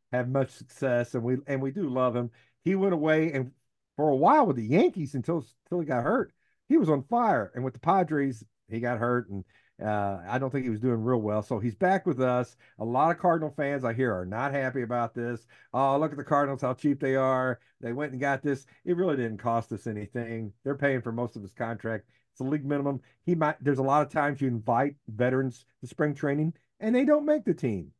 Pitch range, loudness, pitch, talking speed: 120-145 Hz, -28 LUFS, 130 Hz, 240 wpm